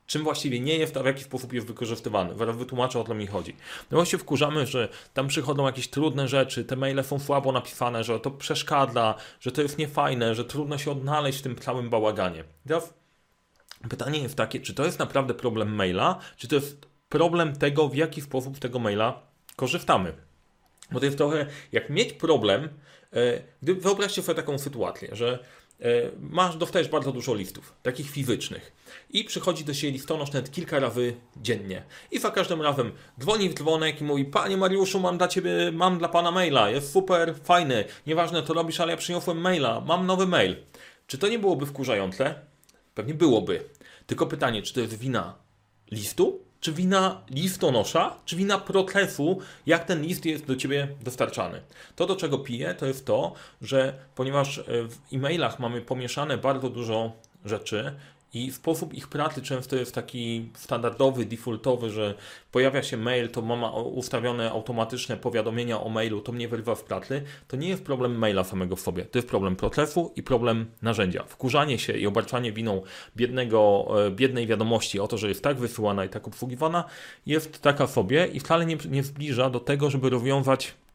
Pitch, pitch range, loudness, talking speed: 135 Hz, 120-160 Hz, -27 LUFS, 175 wpm